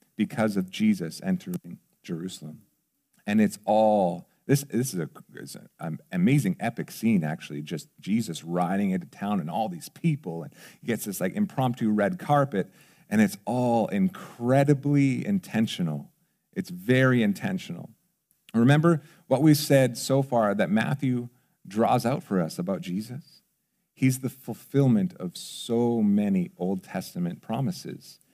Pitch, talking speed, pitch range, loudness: 150 Hz, 140 wpm, 120-185 Hz, -26 LUFS